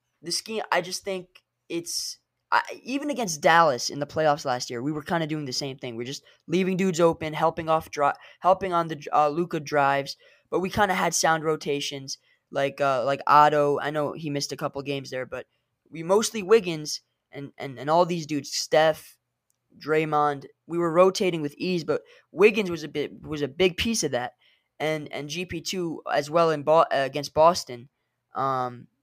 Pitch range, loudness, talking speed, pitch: 140-180 Hz, -25 LUFS, 190 wpm, 155 Hz